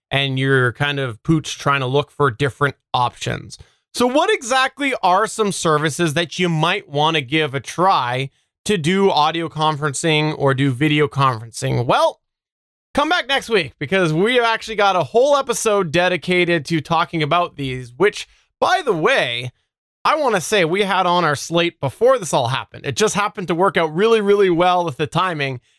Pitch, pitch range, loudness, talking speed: 165 Hz, 145-200 Hz, -18 LUFS, 180 wpm